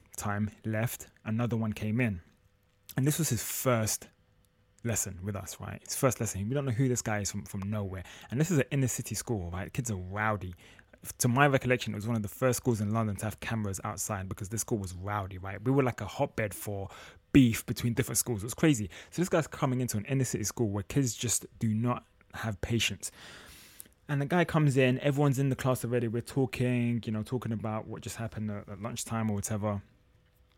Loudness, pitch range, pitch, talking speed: -31 LUFS, 100-125 Hz, 110 Hz, 225 wpm